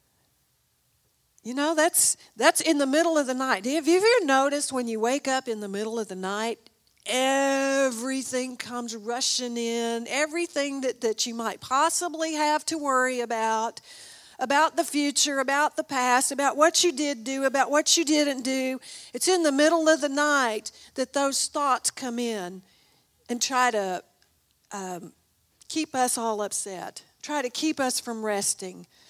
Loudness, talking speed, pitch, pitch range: -25 LUFS, 165 wpm, 265 Hz, 235-295 Hz